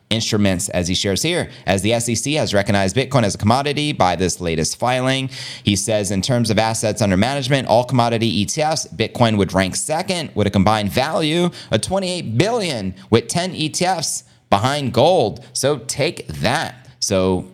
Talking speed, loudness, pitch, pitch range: 170 wpm, -18 LUFS, 115 Hz, 100-140 Hz